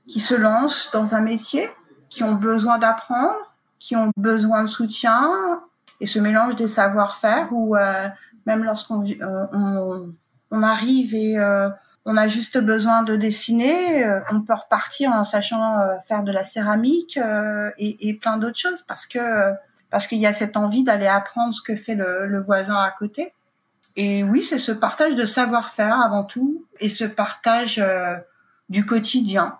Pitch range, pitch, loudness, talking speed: 205-235 Hz, 220 Hz, -20 LUFS, 170 wpm